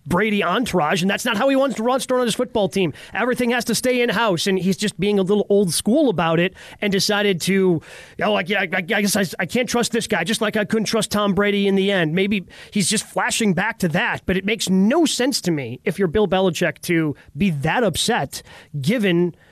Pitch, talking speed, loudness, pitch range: 200 Hz, 245 wpm, -20 LUFS, 185-225 Hz